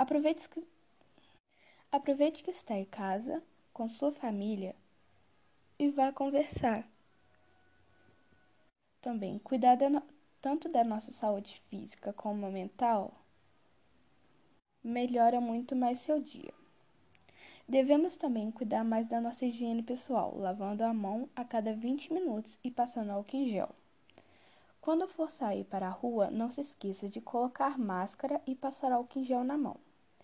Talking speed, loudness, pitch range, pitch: 130 wpm, -34 LUFS, 220-280 Hz, 245 Hz